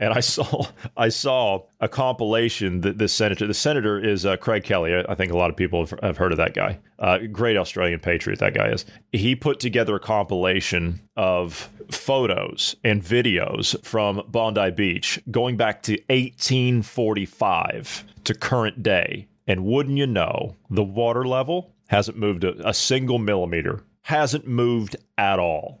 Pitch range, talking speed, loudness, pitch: 95-120 Hz, 165 wpm, -22 LUFS, 105 Hz